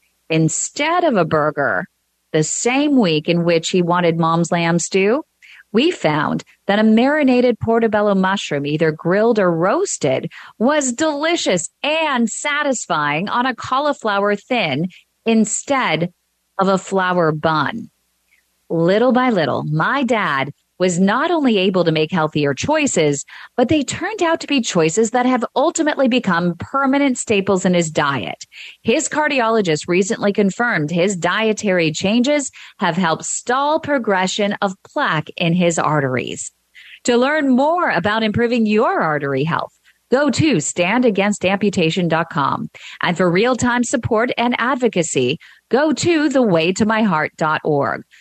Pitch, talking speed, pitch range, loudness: 205 Hz, 130 wpm, 170-255 Hz, -17 LUFS